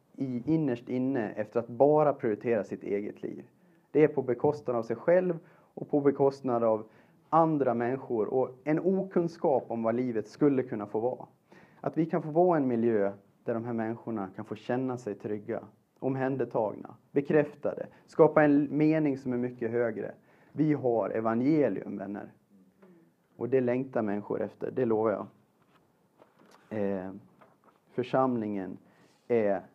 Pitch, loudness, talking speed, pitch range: 125 Hz, -29 LUFS, 145 wpm, 115-150 Hz